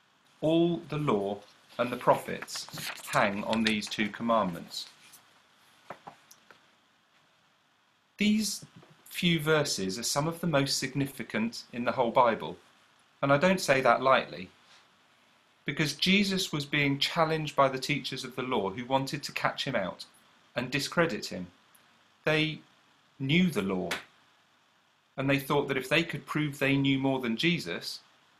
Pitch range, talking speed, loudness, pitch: 135-165 Hz, 140 wpm, -29 LUFS, 145 Hz